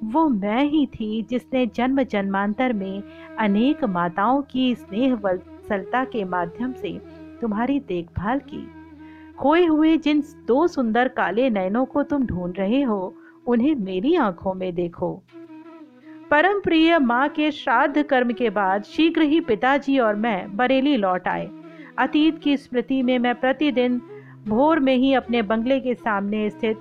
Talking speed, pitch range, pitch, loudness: 150 wpm, 210-295 Hz, 255 Hz, -21 LUFS